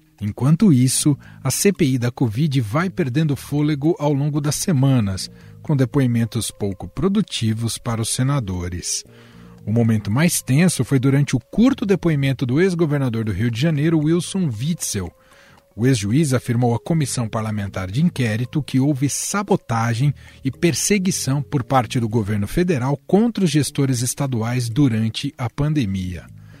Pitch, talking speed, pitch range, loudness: 135 Hz, 140 wpm, 115-155 Hz, -20 LUFS